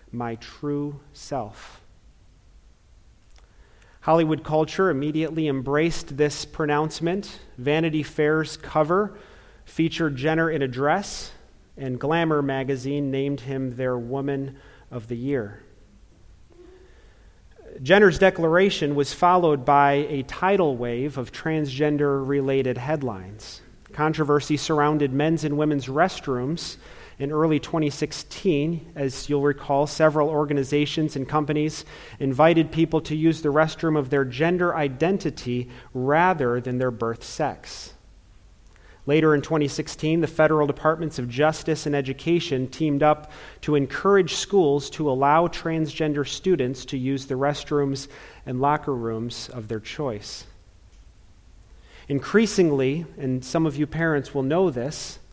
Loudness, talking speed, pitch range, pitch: -23 LUFS, 115 wpm, 130-155 Hz, 145 Hz